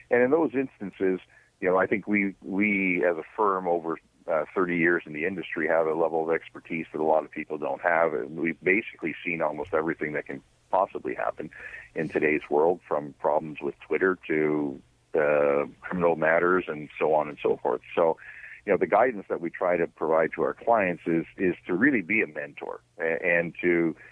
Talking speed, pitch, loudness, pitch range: 200 wpm, 85 Hz, -26 LUFS, 75-95 Hz